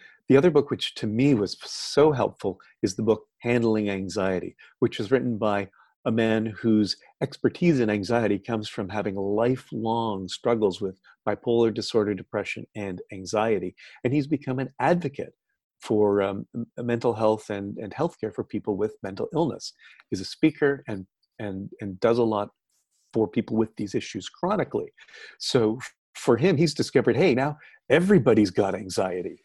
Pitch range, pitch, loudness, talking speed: 105-120 Hz, 110 Hz, -25 LUFS, 160 wpm